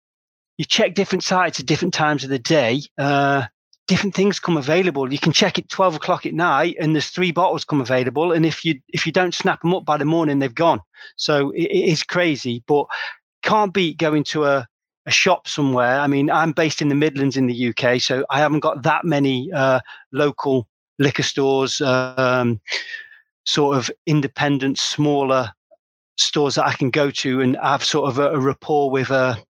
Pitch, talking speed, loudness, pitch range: 150 Hz, 200 wpm, -19 LUFS, 135-170 Hz